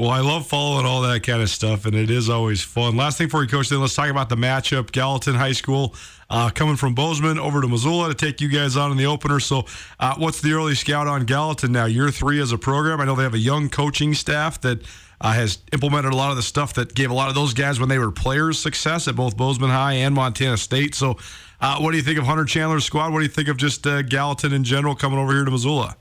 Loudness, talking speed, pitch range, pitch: -20 LUFS, 270 wpm, 125-145 Hz, 135 Hz